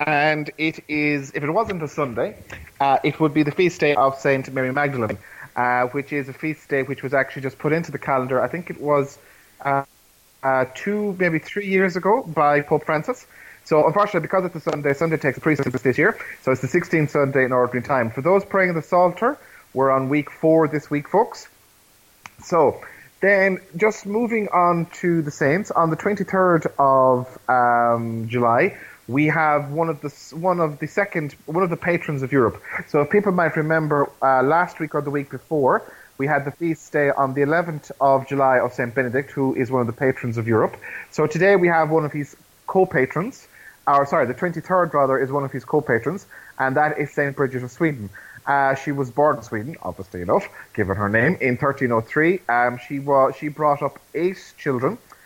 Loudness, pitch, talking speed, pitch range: -21 LUFS, 145 Hz, 205 wpm, 135-165 Hz